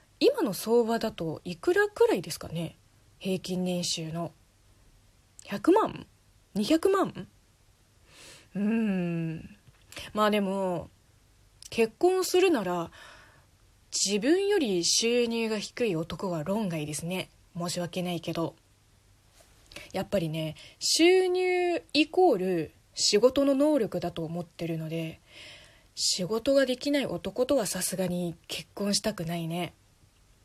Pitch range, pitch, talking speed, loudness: 155-230 Hz, 180 Hz, 210 characters per minute, -28 LUFS